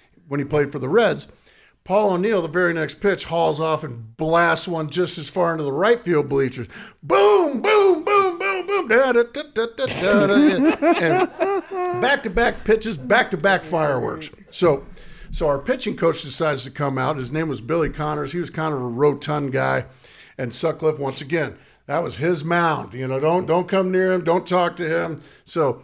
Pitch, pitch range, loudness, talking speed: 170 Hz, 150-220 Hz, -20 LUFS, 185 wpm